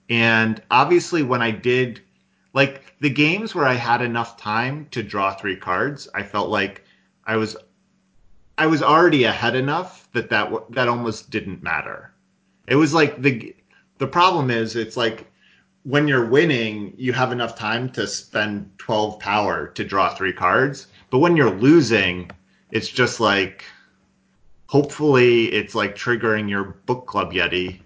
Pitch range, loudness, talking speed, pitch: 105-135 Hz, -20 LUFS, 155 wpm, 115 Hz